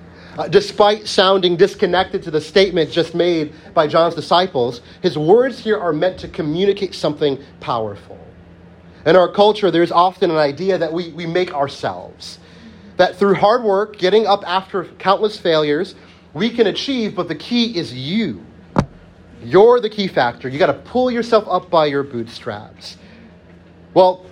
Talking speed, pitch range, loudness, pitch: 160 wpm, 140-195 Hz, -17 LUFS, 175 Hz